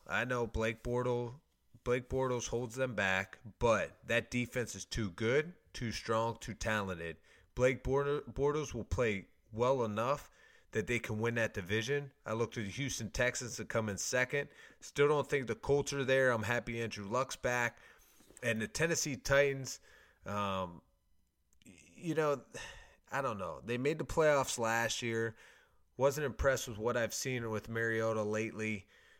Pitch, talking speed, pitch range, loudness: 120 Hz, 160 wpm, 110-135 Hz, -35 LUFS